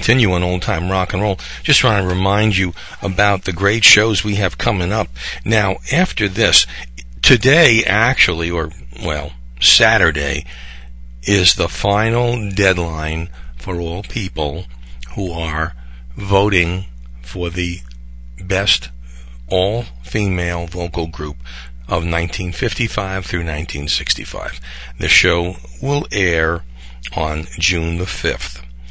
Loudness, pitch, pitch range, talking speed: -16 LUFS, 85 Hz, 60-100 Hz, 120 wpm